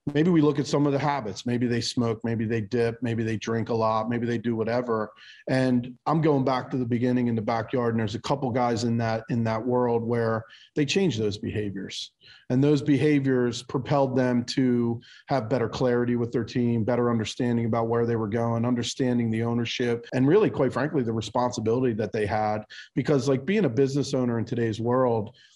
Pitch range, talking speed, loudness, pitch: 115-130 Hz, 205 wpm, -25 LUFS, 120 Hz